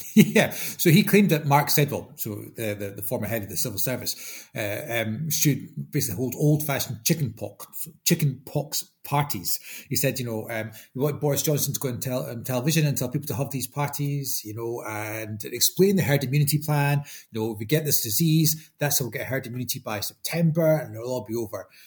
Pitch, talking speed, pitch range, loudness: 135 Hz, 220 wpm, 115-150 Hz, -25 LUFS